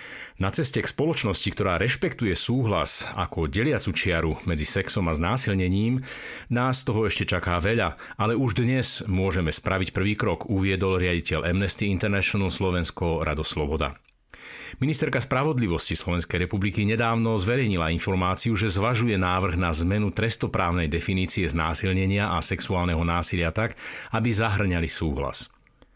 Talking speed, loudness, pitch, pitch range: 125 wpm, -25 LUFS, 95 Hz, 85-110 Hz